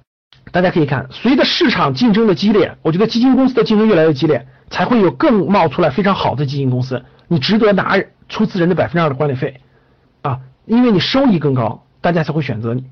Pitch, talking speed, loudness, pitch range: 165 Hz, 350 characters per minute, -14 LUFS, 140-215 Hz